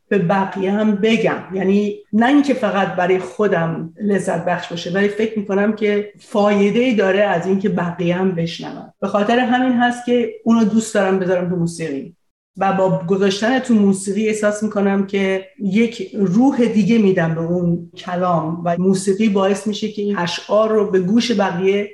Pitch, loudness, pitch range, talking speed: 200 Hz, -17 LUFS, 185-215 Hz, 170 wpm